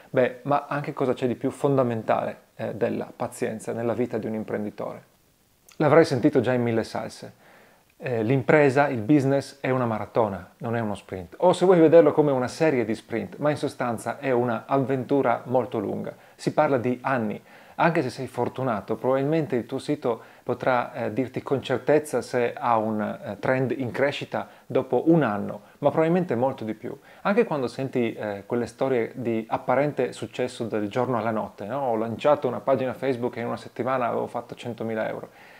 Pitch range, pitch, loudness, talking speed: 115-140 Hz, 125 Hz, -25 LUFS, 180 wpm